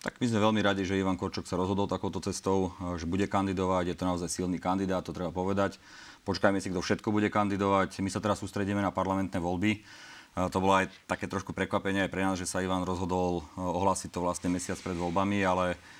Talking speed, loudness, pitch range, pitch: 210 wpm, -30 LUFS, 90-100 Hz, 95 Hz